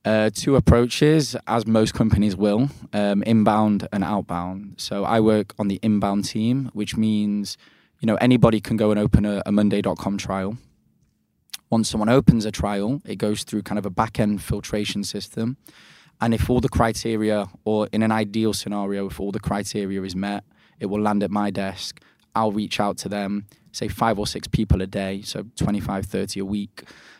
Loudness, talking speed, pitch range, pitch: -22 LUFS, 190 wpm, 100-110 Hz, 105 Hz